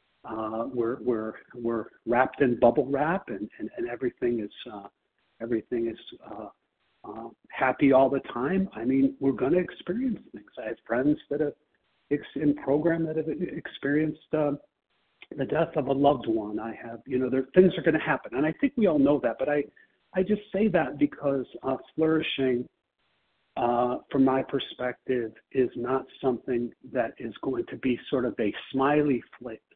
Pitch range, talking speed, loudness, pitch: 120-155 Hz, 185 wpm, -27 LUFS, 135 Hz